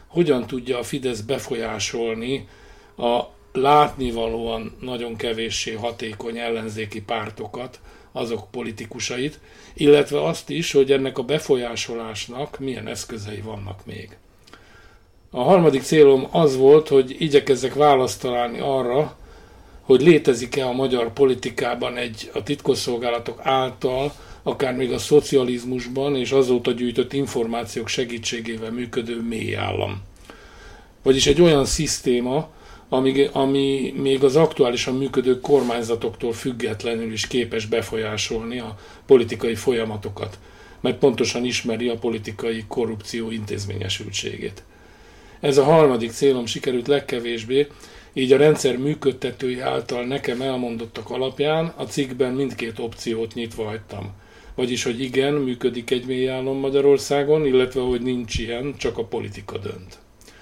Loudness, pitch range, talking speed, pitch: -21 LUFS, 115-135 Hz, 115 wpm, 125 Hz